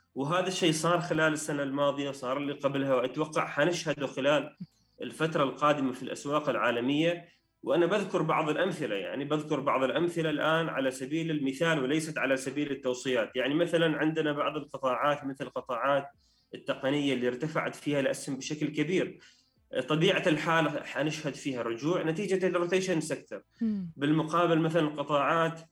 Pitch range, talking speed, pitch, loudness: 135-165 Hz, 135 wpm, 150 Hz, -30 LUFS